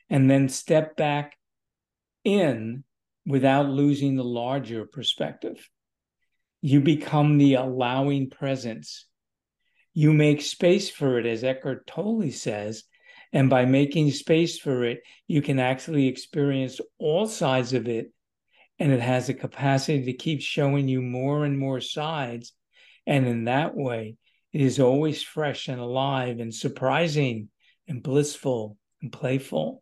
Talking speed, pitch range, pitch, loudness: 135 wpm, 125-145 Hz, 135 Hz, -24 LUFS